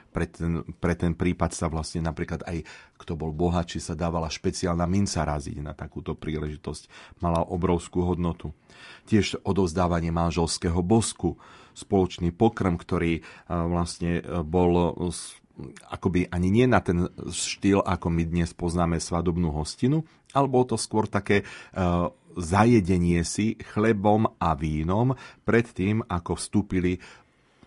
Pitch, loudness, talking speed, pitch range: 90 Hz, -26 LUFS, 125 wpm, 85-100 Hz